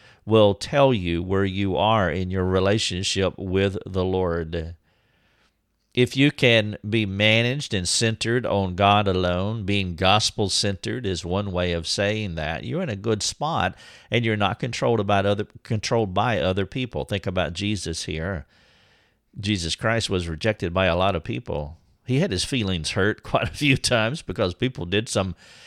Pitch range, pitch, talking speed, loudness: 90-110 Hz, 100 Hz, 170 wpm, -23 LUFS